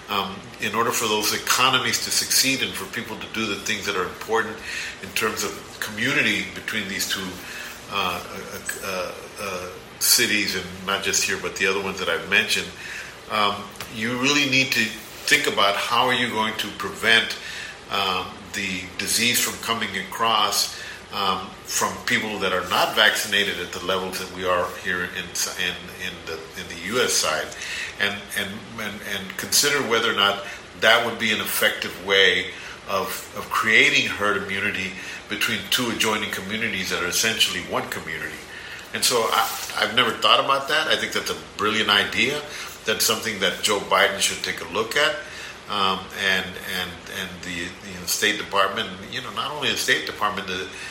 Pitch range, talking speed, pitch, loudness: 95-110 Hz, 180 wpm, 100 Hz, -22 LUFS